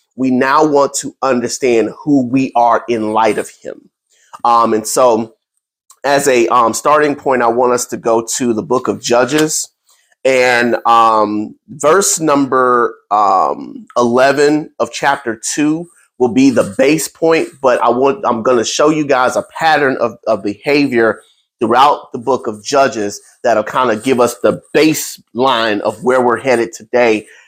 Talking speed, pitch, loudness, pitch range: 160 wpm, 125 Hz, -13 LUFS, 115-145 Hz